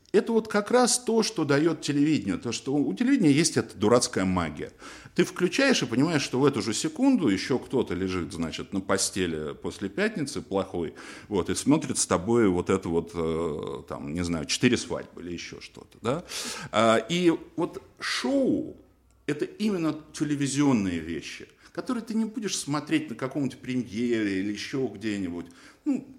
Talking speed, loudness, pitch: 160 wpm, -27 LUFS, 135 Hz